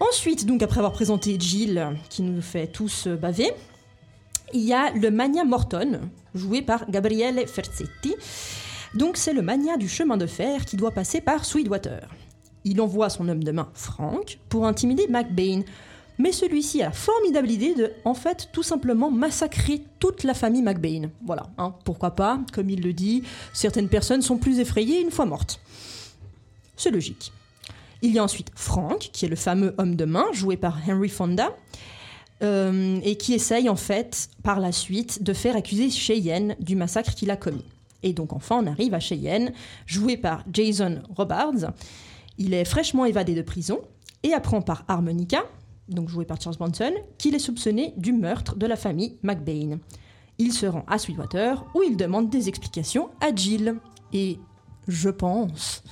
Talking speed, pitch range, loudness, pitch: 175 wpm, 175-240 Hz, -25 LUFS, 200 Hz